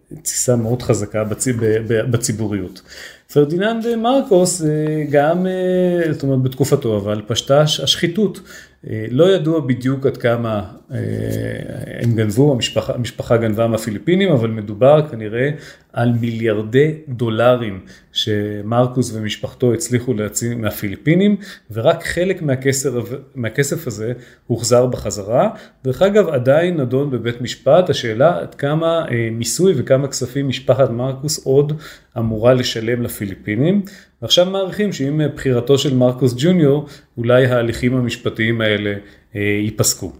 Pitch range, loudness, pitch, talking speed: 115-145 Hz, -17 LUFS, 125 Hz, 110 wpm